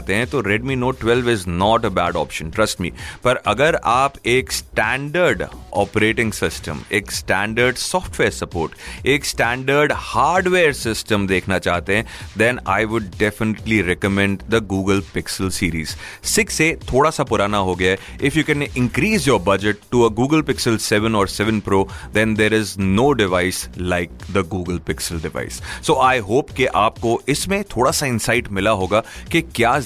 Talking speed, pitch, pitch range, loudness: 165 wpm, 105 Hz, 95-120 Hz, -19 LUFS